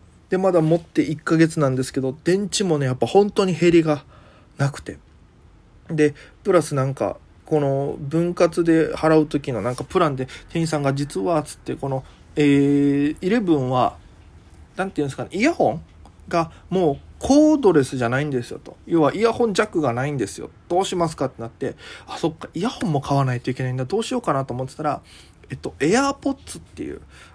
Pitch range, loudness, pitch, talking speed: 130-175 Hz, -21 LUFS, 150 Hz, 375 characters per minute